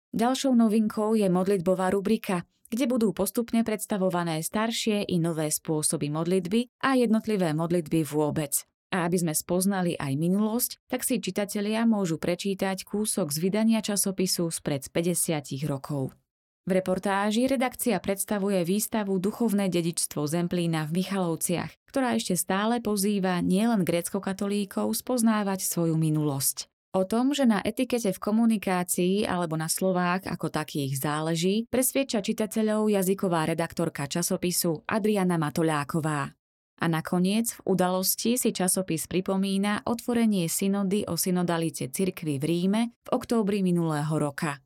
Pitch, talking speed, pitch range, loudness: 190 Hz, 125 wpm, 170-215 Hz, -27 LUFS